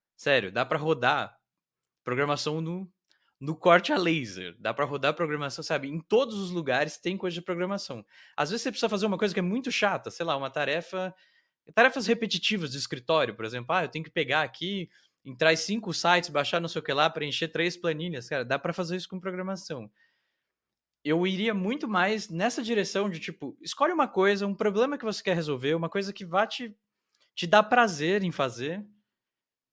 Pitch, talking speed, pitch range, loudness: 175 Hz, 195 wpm, 155-205 Hz, -28 LUFS